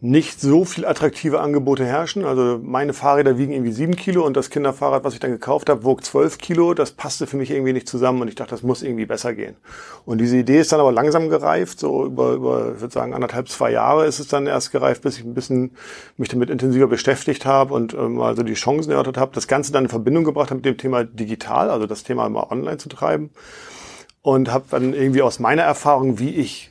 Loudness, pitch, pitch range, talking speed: -19 LUFS, 135 Hz, 125-145 Hz, 235 wpm